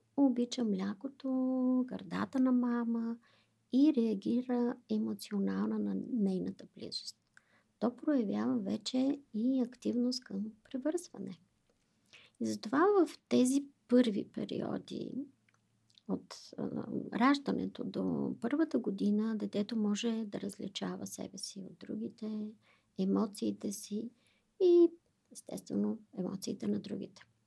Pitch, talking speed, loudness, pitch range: 230 Hz, 95 wpm, -34 LUFS, 210-260 Hz